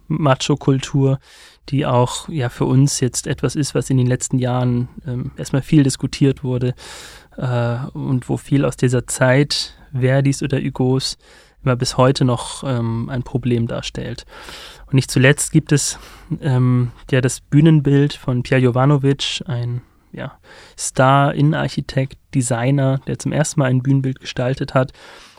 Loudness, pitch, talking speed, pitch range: -18 LUFS, 135 Hz, 145 wpm, 125-140 Hz